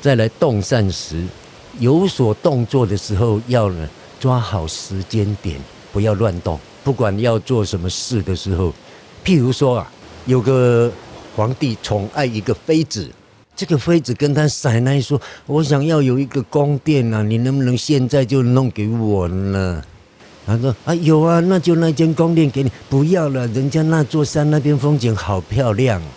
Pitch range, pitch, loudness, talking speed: 105-145 Hz, 125 Hz, -17 LUFS, 240 characters per minute